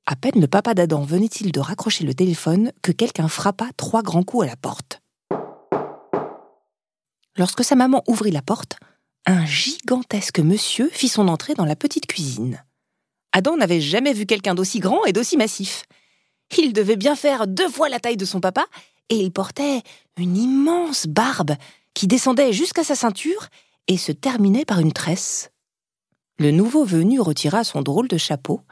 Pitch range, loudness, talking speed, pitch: 175-255 Hz, -20 LUFS, 170 wpm, 205 Hz